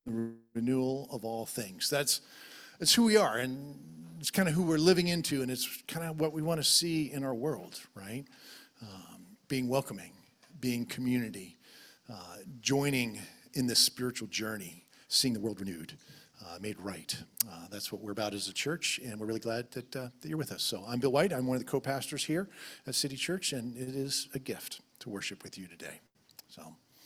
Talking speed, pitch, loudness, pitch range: 200 wpm, 130 Hz, -32 LUFS, 115-150 Hz